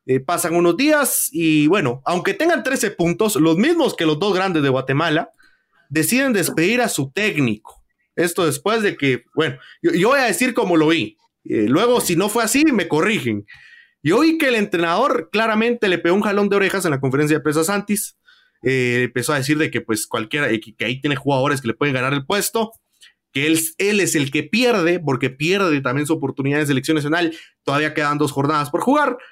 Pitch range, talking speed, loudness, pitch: 145-215 Hz, 205 wpm, -18 LUFS, 165 Hz